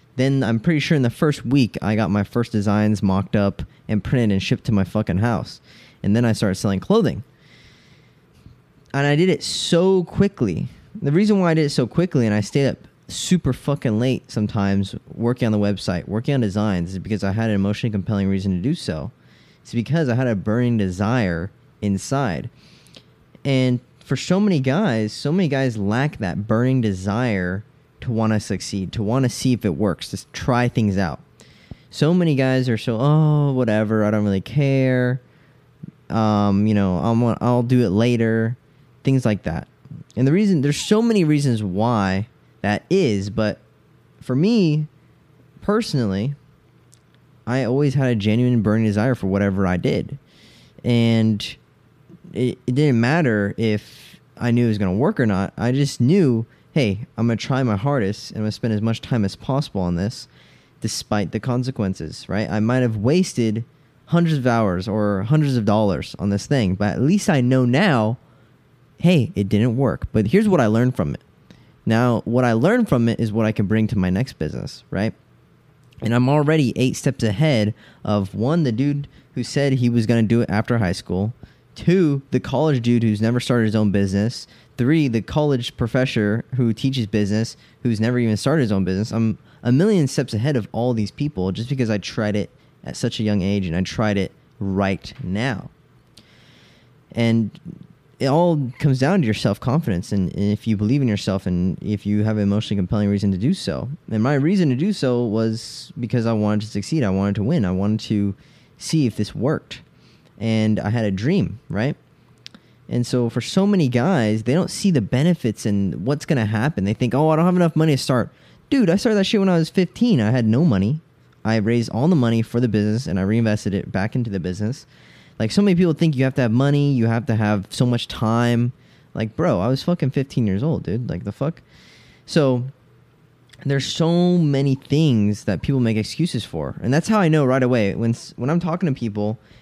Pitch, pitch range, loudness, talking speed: 120 Hz, 105-140 Hz, -20 LUFS, 200 wpm